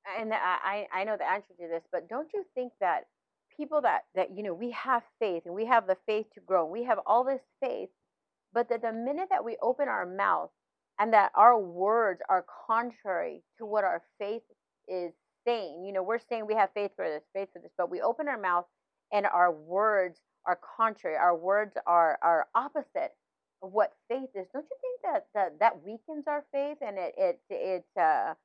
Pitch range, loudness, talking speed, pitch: 185-255 Hz, -30 LUFS, 210 wpm, 220 Hz